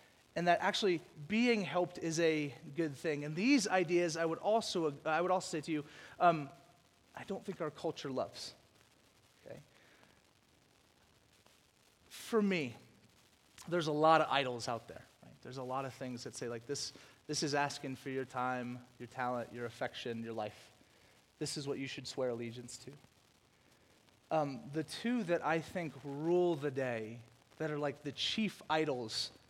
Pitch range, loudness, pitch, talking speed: 125-170 Hz, -36 LUFS, 150 Hz, 170 wpm